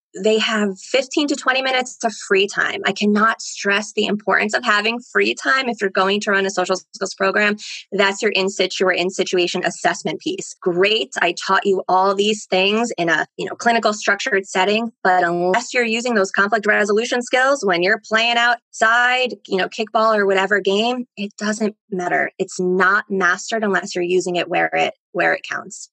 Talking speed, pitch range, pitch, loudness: 190 wpm, 190-225 Hz, 205 Hz, -18 LUFS